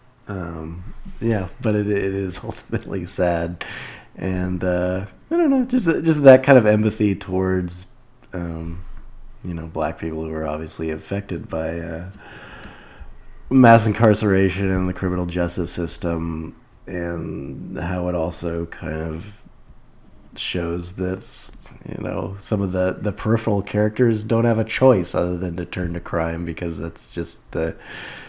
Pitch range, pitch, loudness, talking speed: 85-105 Hz, 90 Hz, -21 LUFS, 145 wpm